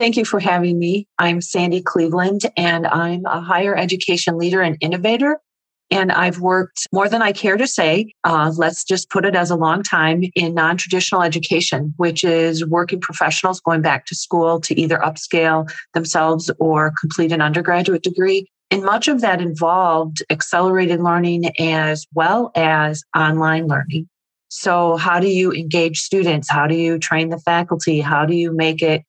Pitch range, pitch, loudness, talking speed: 160-185 Hz, 170 Hz, -17 LUFS, 175 wpm